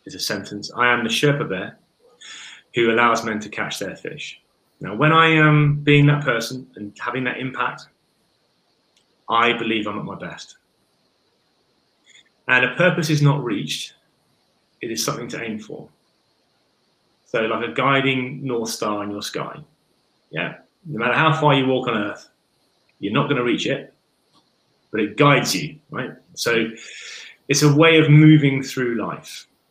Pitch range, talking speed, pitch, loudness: 115-150 Hz, 165 wpm, 130 Hz, -19 LUFS